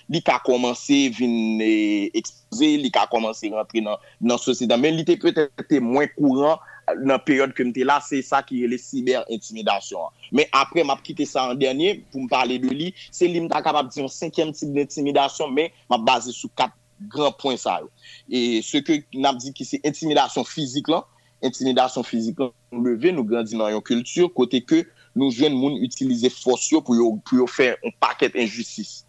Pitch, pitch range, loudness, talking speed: 135 Hz, 120-160 Hz, -22 LUFS, 190 wpm